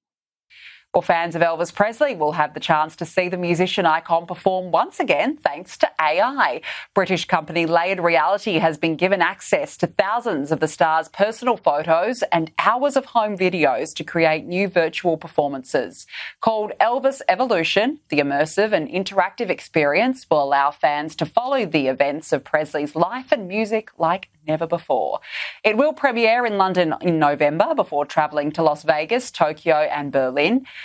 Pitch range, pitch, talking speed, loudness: 155-210 Hz, 170 Hz, 160 wpm, -20 LUFS